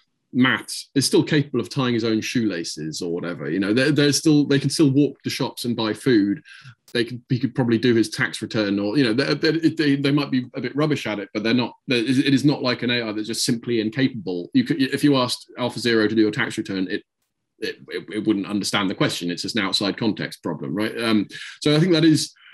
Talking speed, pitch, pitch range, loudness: 250 wpm, 125 Hz, 110-140 Hz, -21 LUFS